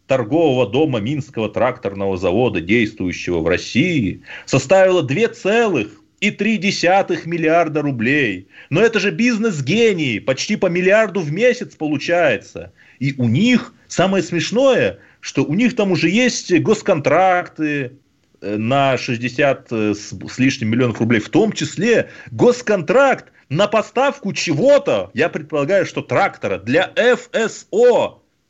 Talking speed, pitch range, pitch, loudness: 115 wpm, 135-210 Hz, 170 Hz, -17 LUFS